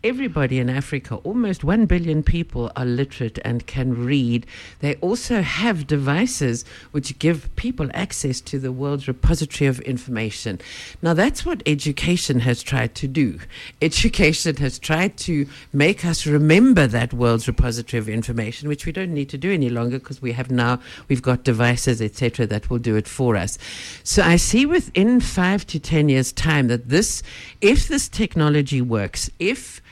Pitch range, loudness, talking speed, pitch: 120-165 Hz, -21 LUFS, 170 wpm, 140 Hz